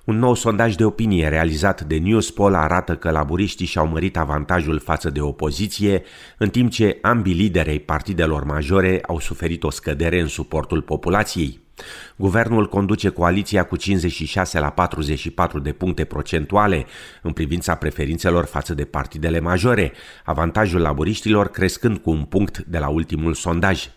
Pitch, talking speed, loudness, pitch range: 85 Hz, 150 wpm, -20 LUFS, 80-100 Hz